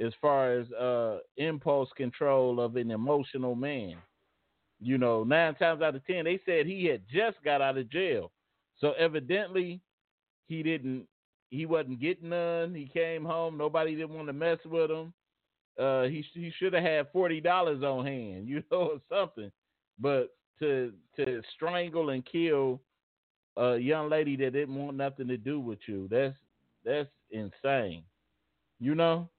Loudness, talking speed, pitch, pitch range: -31 LUFS, 160 wpm, 150 Hz, 130-165 Hz